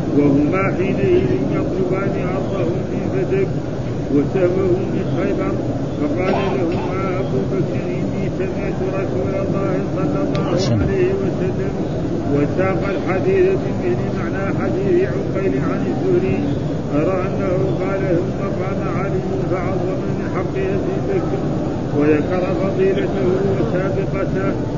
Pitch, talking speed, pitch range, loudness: 175 Hz, 100 wpm, 145-185 Hz, -19 LUFS